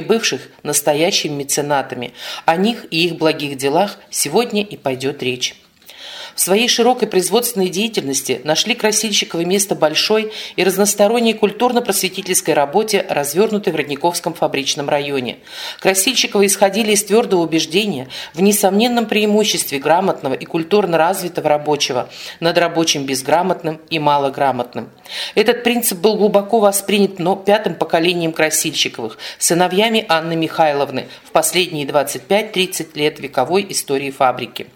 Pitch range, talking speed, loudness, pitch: 150-205 Hz, 115 wpm, -16 LUFS, 175 Hz